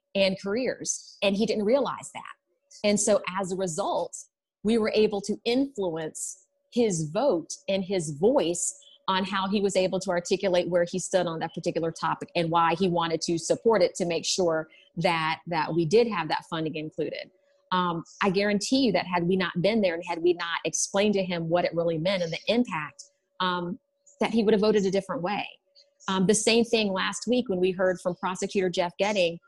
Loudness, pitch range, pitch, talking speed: -26 LUFS, 175-215 Hz, 190 Hz, 205 wpm